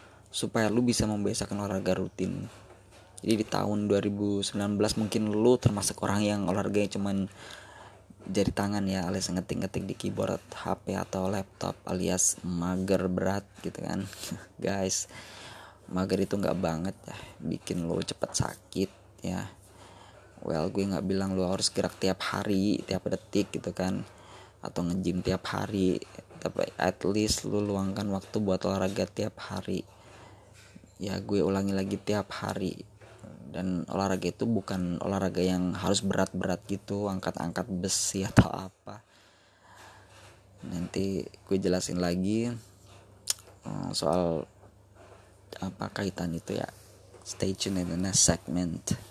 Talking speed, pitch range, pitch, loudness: 125 wpm, 95-105 Hz, 95 Hz, -30 LUFS